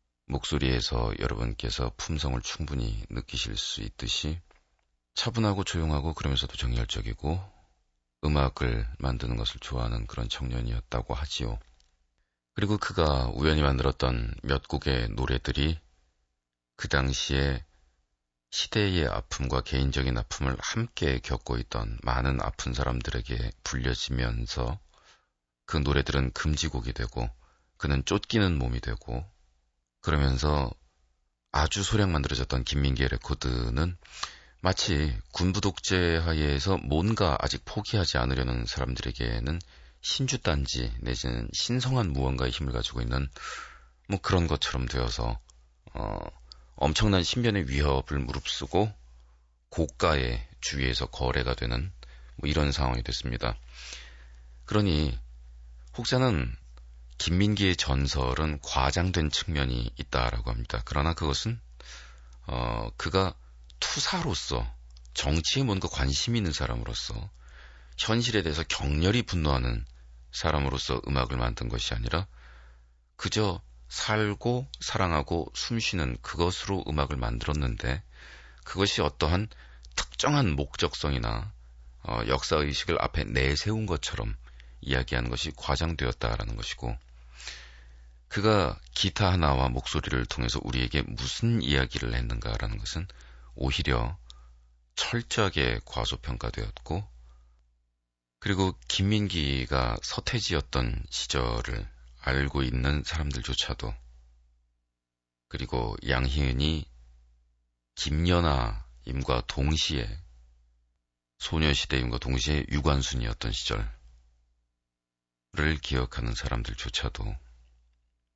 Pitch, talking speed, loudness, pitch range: 65 Hz, 260 characters per minute, -29 LUFS, 60-80 Hz